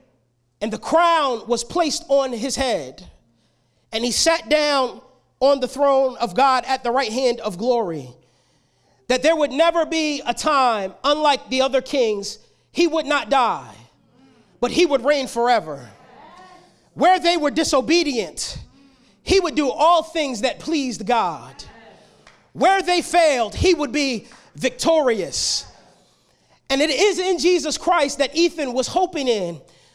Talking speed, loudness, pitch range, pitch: 145 wpm, -20 LUFS, 235-320 Hz, 270 Hz